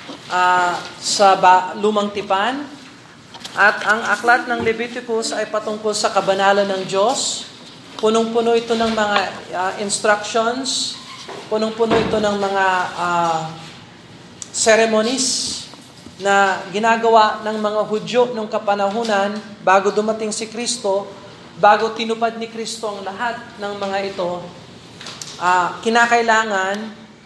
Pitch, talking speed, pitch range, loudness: 215 Hz, 110 wpm, 195-225 Hz, -18 LUFS